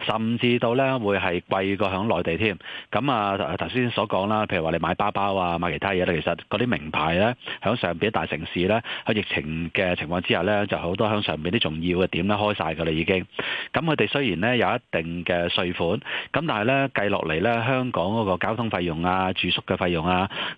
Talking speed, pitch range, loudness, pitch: 315 characters per minute, 85-115 Hz, -24 LUFS, 95 Hz